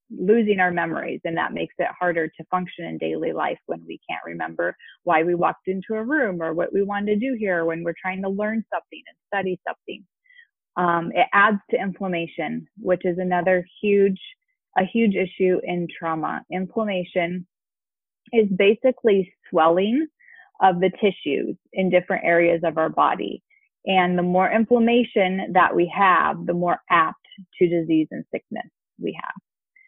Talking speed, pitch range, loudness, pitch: 165 wpm, 175-210 Hz, -22 LUFS, 185 Hz